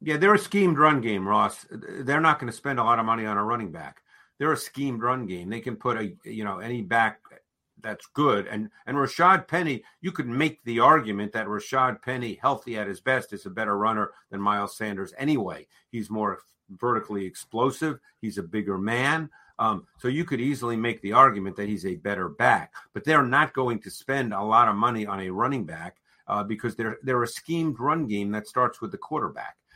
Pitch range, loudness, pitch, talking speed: 105-135 Hz, -25 LUFS, 115 Hz, 215 wpm